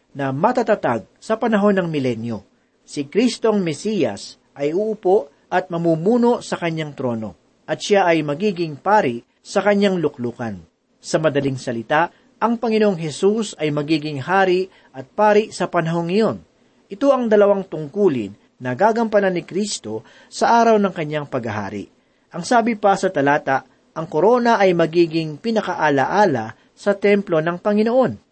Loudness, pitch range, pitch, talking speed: -19 LUFS, 140-210 Hz, 175 Hz, 140 wpm